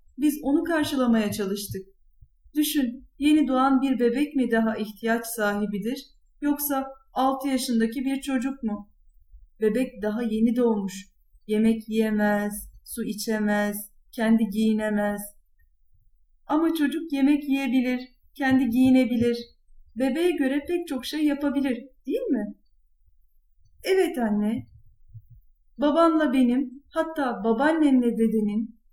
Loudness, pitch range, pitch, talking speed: -25 LUFS, 215-275 Hz, 240 Hz, 105 wpm